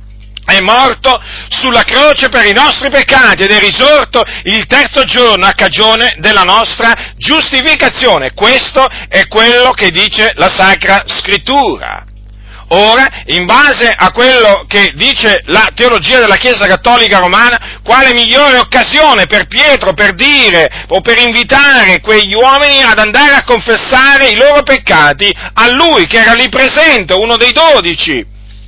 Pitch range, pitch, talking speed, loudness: 205-270 Hz, 240 Hz, 140 wpm, -5 LUFS